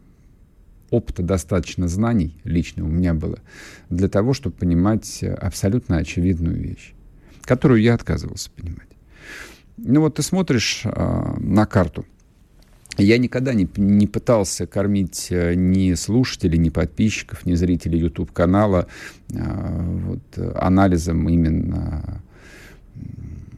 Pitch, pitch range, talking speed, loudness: 95 Hz, 85-110 Hz, 105 wpm, -20 LUFS